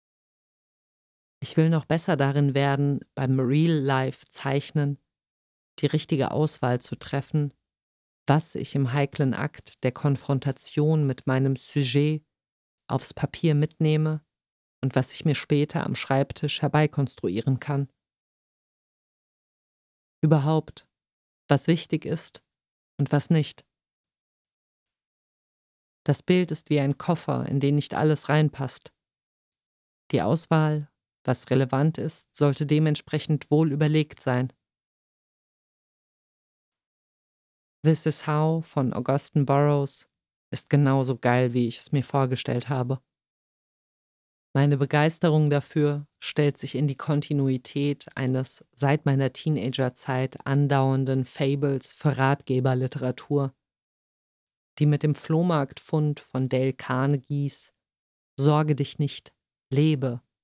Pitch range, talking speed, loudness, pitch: 130-150 Hz, 105 wpm, -25 LUFS, 140 Hz